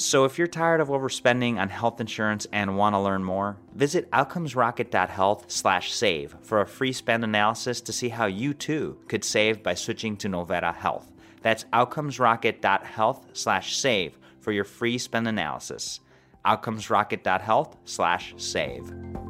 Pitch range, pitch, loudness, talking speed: 100-125 Hz, 110 Hz, -25 LUFS, 145 wpm